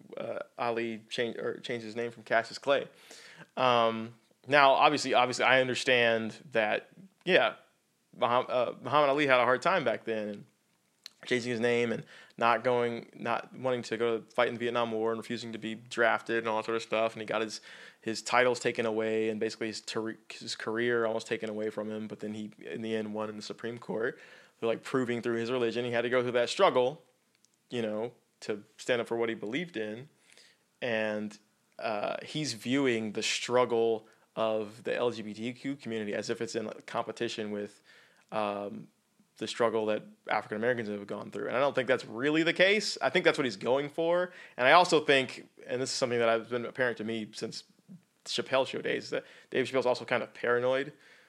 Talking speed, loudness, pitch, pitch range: 205 wpm, -30 LUFS, 115 Hz, 110-125 Hz